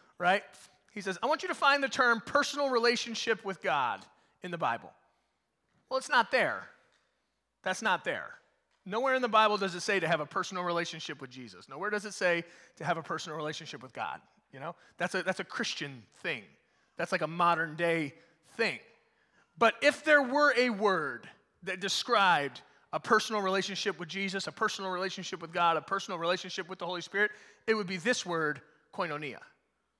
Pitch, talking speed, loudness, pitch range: 190 Hz, 190 wpm, -31 LUFS, 170-225 Hz